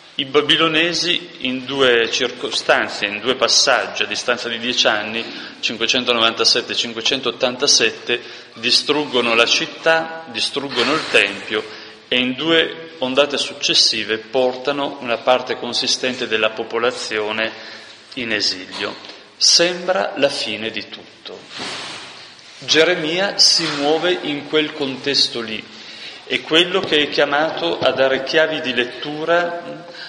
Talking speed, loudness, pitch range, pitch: 110 wpm, -17 LUFS, 120-160 Hz, 135 Hz